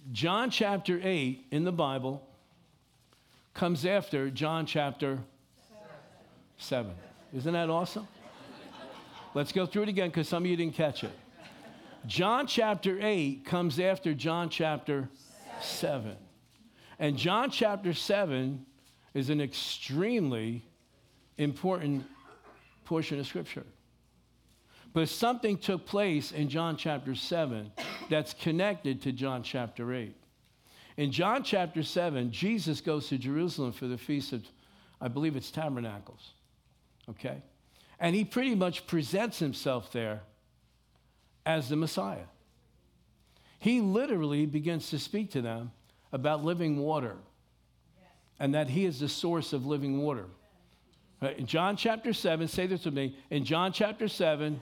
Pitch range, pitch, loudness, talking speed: 135-180 Hz, 150 Hz, -32 LUFS, 130 wpm